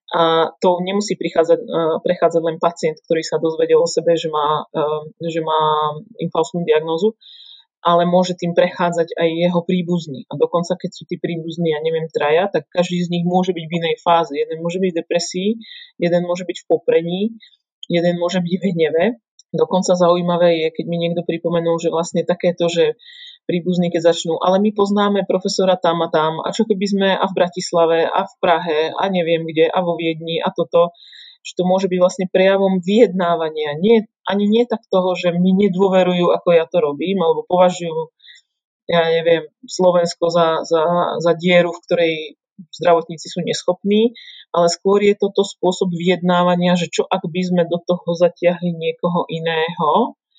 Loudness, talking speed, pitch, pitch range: -18 LUFS, 175 wpm, 175 Hz, 165-190 Hz